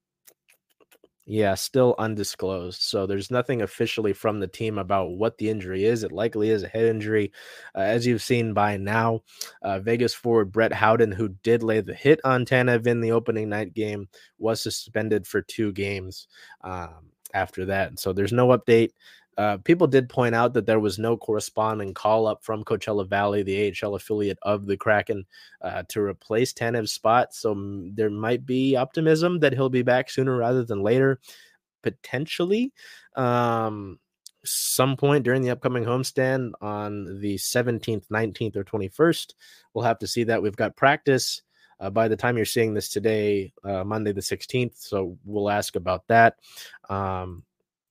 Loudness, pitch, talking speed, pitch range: -24 LUFS, 110 Hz, 170 wpm, 100-120 Hz